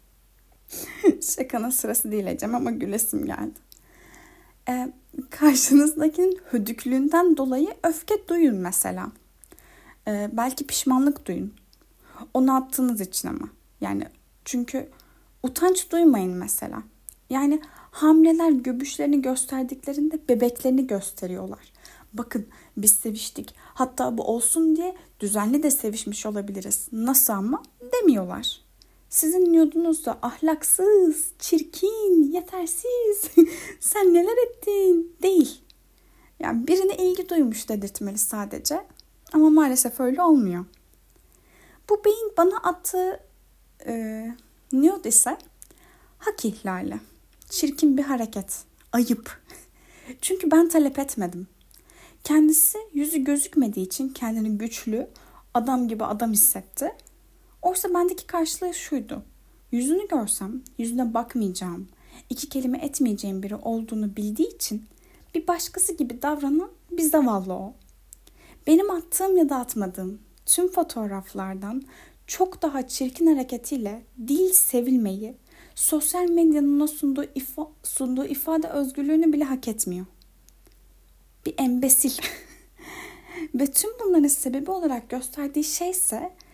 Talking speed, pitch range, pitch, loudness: 105 wpm, 235-340 Hz, 285 Hz, -23 LUFS